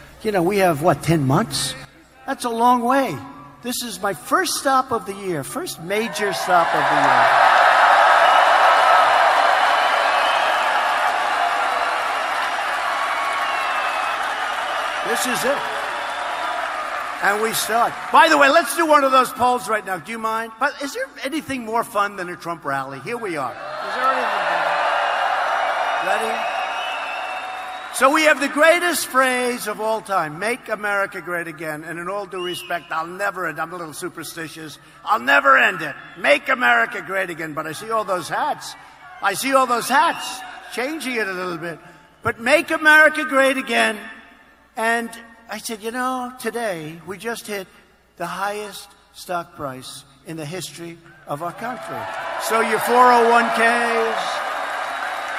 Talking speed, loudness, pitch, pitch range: 150 wpm, -19 LUFS, 210 Hz, 175-250 Hz